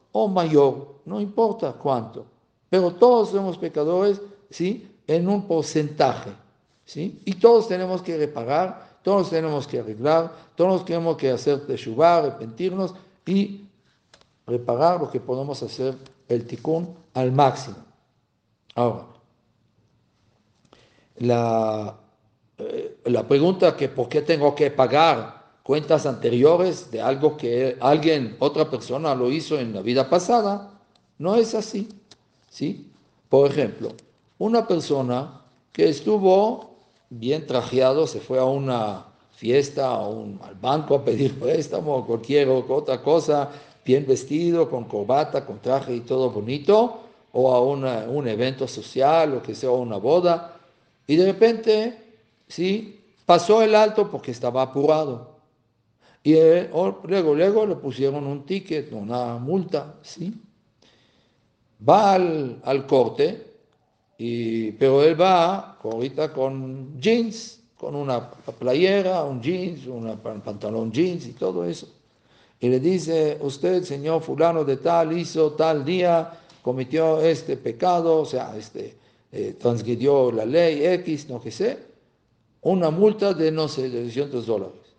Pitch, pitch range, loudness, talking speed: 150 Hz, 125-180 Hz, -22 LUFS, 135 wpm